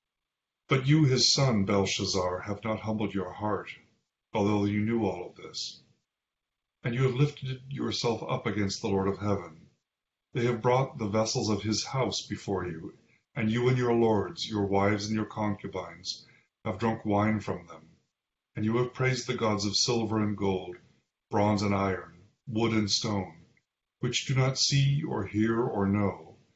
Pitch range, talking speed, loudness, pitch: 100-125 Hz, 170 wpm, -29 LUFS, 110 Hz